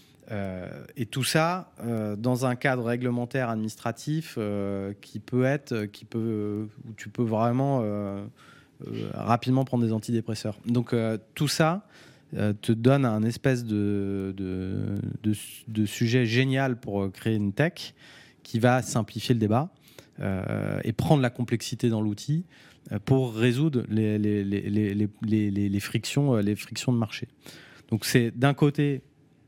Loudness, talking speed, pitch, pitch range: -27 LUFS, 150 wpm, 115 Hz, 105-130 Hz